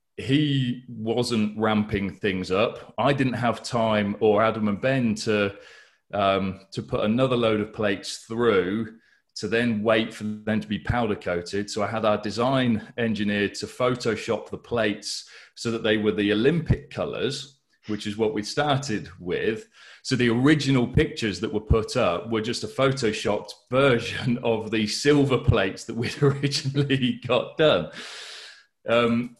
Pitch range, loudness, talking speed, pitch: 105-125 Hz, -24 LUFS, 155 wpm, 110 Hz